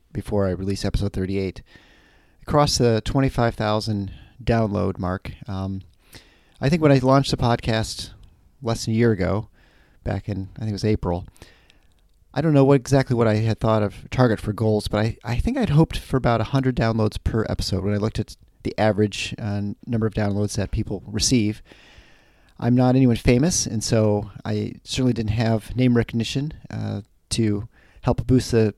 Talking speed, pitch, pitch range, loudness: 175 wpm, 110 Hz, 100-120 Hz, -22 LUFS